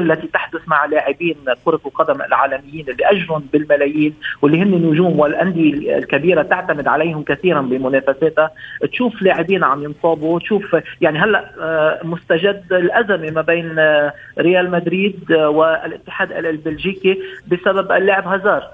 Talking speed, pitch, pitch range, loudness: 115 wpm, 160 Hz, 150-185 Hz, -16 LUFS